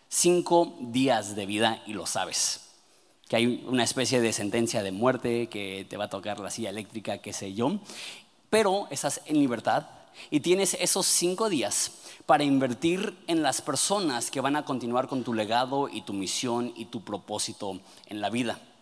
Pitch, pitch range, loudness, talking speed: 120 Hz, 105-165 Hz, -27 LUFS, 180 wpm